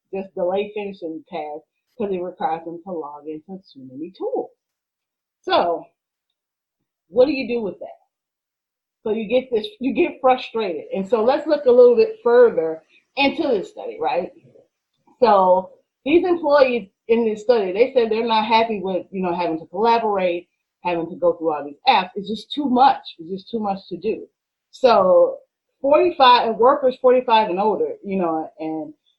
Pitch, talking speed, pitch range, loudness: 225 Hz, 175 wpm, 180-285 Hz, -19 LUFS